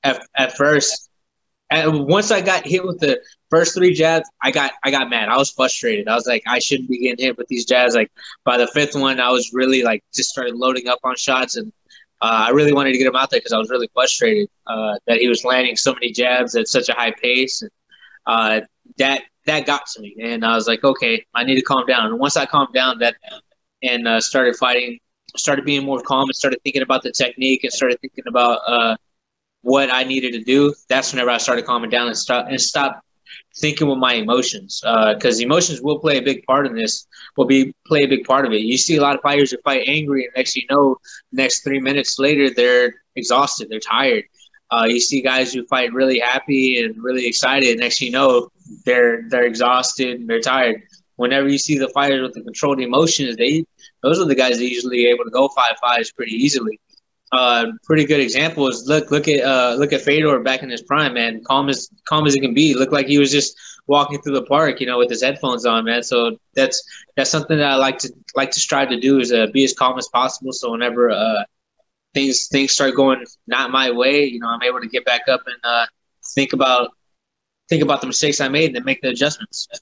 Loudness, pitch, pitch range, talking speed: -17 LUFS, 130 Hz, 125-145 Hz, 240 wpm